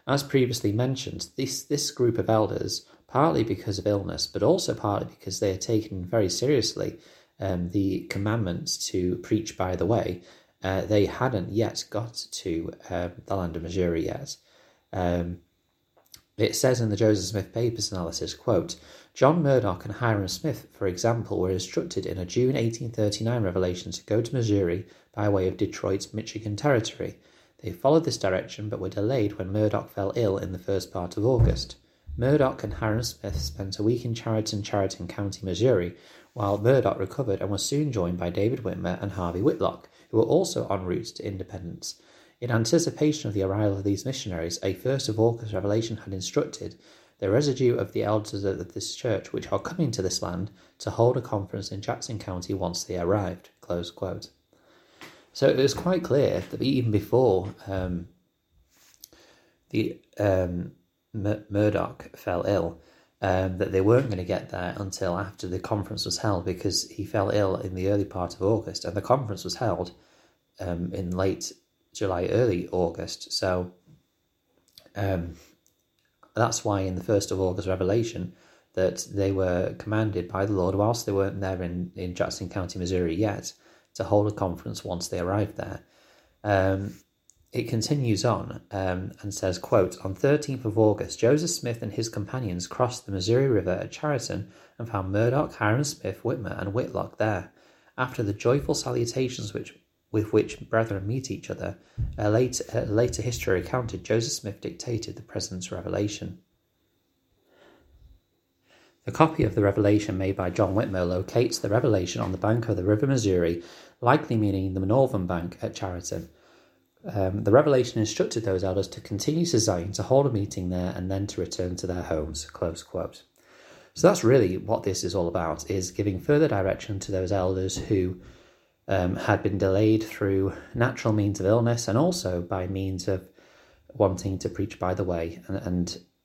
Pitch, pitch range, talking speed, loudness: 100 Hz, 95-115 Hz, 170 wpm, -27 LUFS